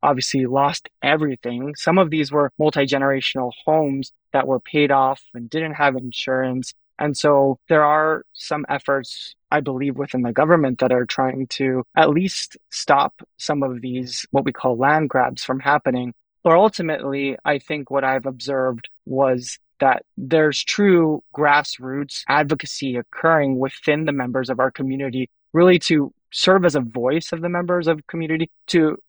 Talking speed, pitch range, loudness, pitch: 160 wpm, 130-155 Hz, -20 LUFS, 140 Hz